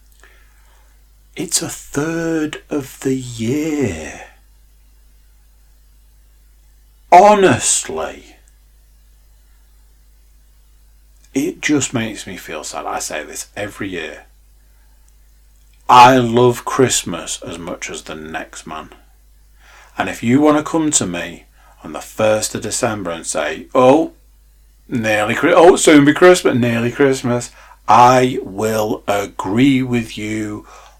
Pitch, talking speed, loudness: 85 Hz, 105 wpm, -15 LUFS